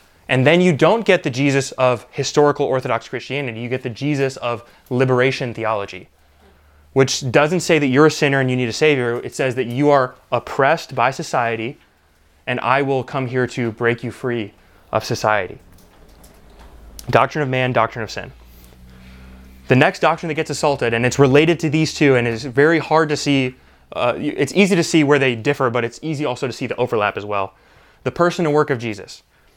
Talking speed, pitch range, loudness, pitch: 195 wpm, 115-145 Hz, -18 LUFS, 130 Hz